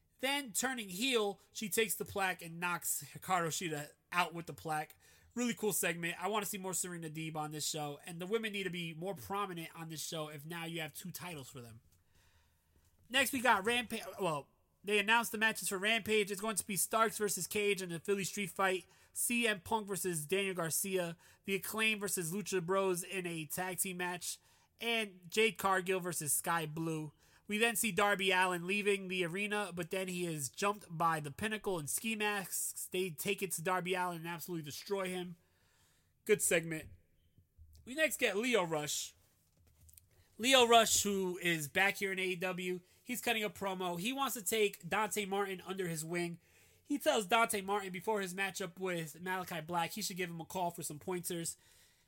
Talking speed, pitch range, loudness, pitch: 190 wpm, 165-205 Hz, -35 LUFS, 185 Hz